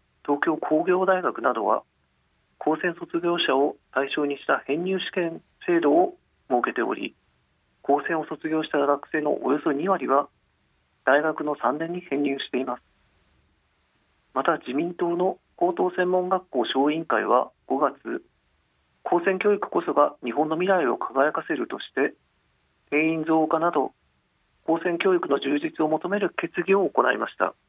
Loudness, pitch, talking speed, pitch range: -25 LUFS, 160 Hz, 265 characters per minute, 140-180 Hz